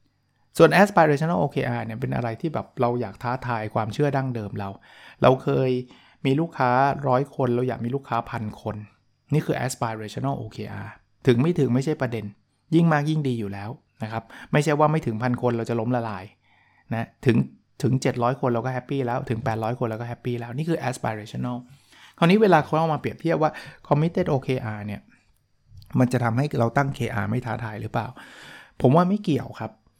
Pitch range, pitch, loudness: 115-140 Hz, 125 Hz, -24 LUFS